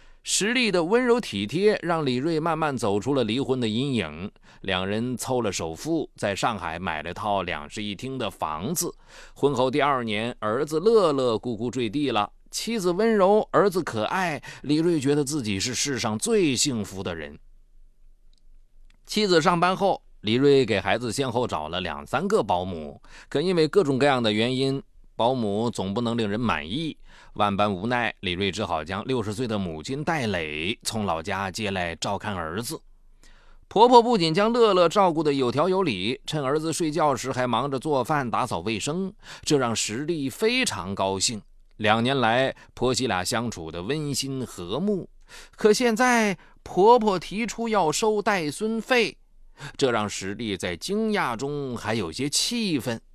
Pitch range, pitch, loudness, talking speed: 105-170 Hz, 130 Hz, -24 LUFS, 240 characters per minute